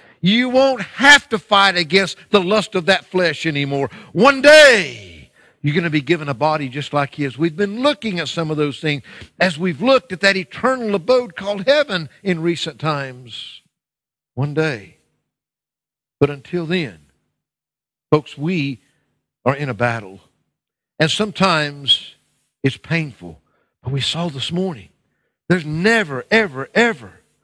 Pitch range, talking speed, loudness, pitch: 140-200 Hz, 150 wpm, -17 LUFS, 165 Hz